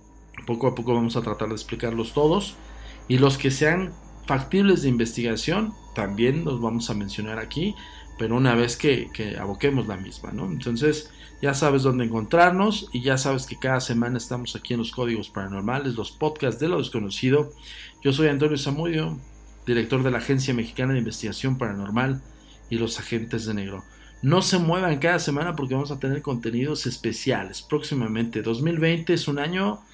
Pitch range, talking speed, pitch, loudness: 115-150 Hz, 170 wpm, 130 Hz, -24 LUFS